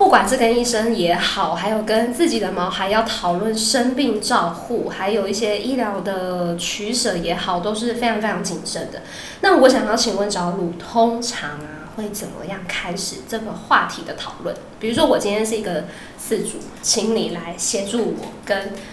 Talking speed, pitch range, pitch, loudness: 270 characters per minute, 185-230 Hz, 210 Hz, -20 LUFS